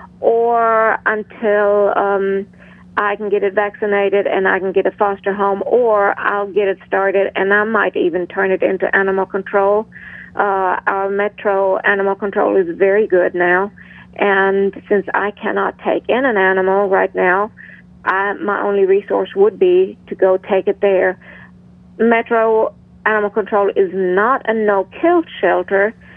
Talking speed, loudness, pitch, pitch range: 155 wpm, -16 LUFS, 200 Hz, 195-210 Hz